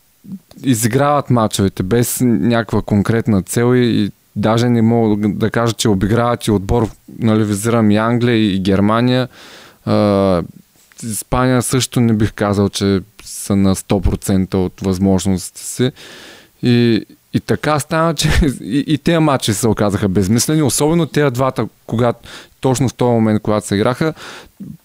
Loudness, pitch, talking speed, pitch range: -15 LUFS, 115 Hz, 140 wpm, 100-125 Hz